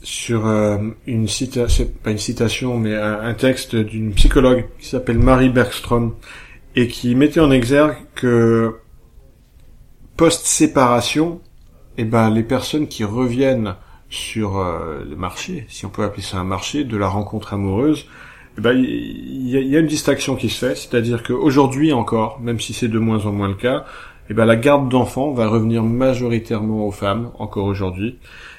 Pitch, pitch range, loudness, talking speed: 115 Hz, 105-130 Hz, -18 LUFS, 160 wpm